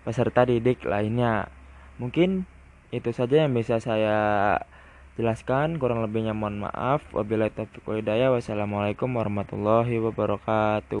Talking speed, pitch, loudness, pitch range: 100 wpm, 110 Hz, -25 LUFS, 105-120 Hz